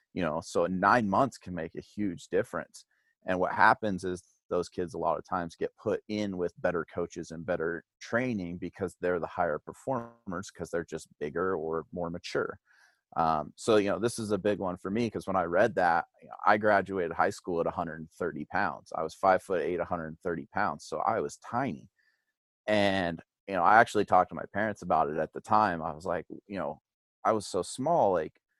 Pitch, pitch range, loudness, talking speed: 95 Hz, 85-105 Hz, -30 LUFS, 210 wpm